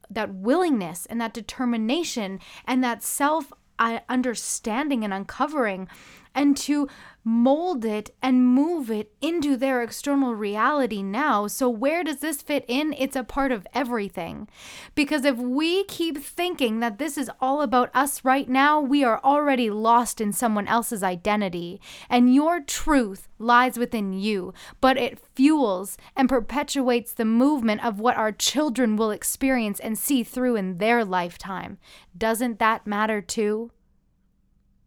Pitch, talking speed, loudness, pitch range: 245 Hz, 145 wpm, -24 LUFS, 220-275 Hz